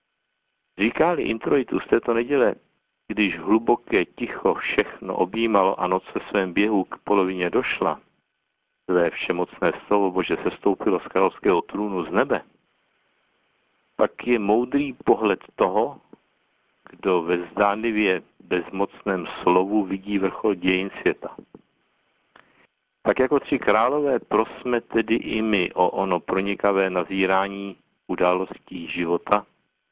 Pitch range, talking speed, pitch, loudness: 95-110 Hz, 115 wpm, 100 Hz, -23 LUFS